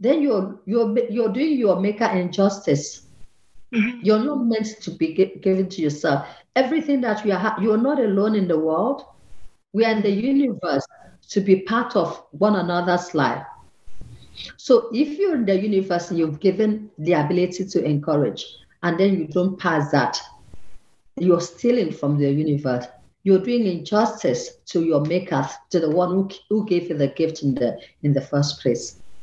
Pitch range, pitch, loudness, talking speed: 165-220 Hz, 190 Hz, -21 LUFS, 170 wpm